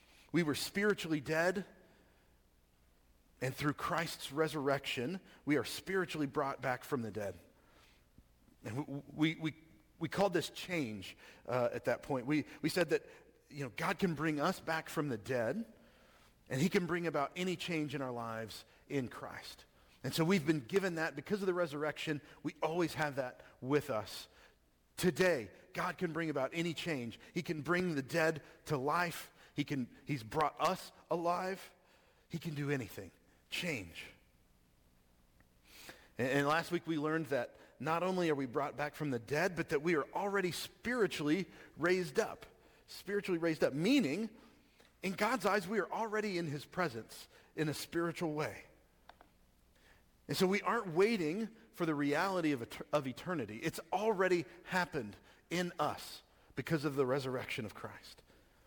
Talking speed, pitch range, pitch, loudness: 165 wpm, 130-180 Hz, 155 Hz, -37 LUFS